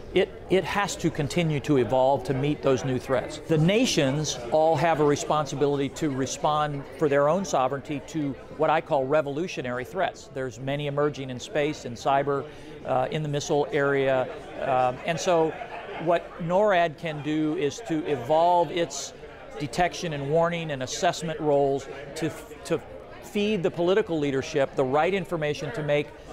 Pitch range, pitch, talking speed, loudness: 140-165 Hz, 150 Hz, 160 wpm, -26 LUFS